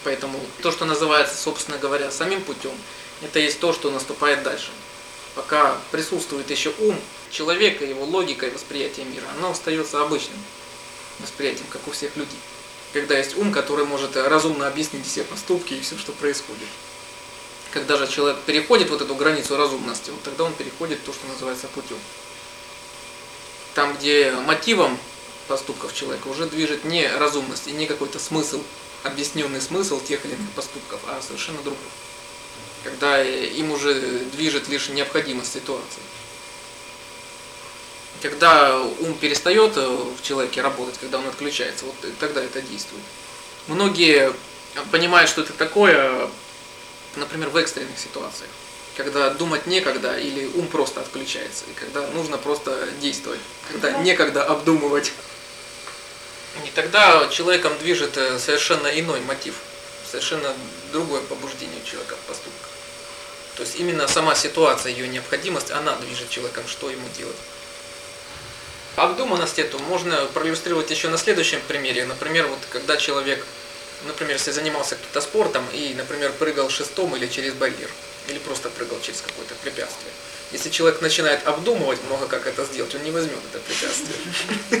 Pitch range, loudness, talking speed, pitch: 140-160 Hz, -22 LUFS, 140 wpm, 145 Hz